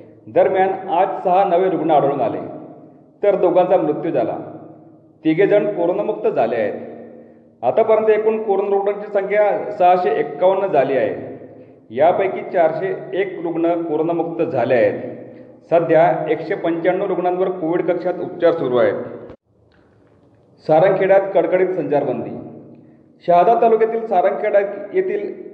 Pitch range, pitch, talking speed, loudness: 165-205 Hz, 185 Hz, 115 wpm, -17 LUFS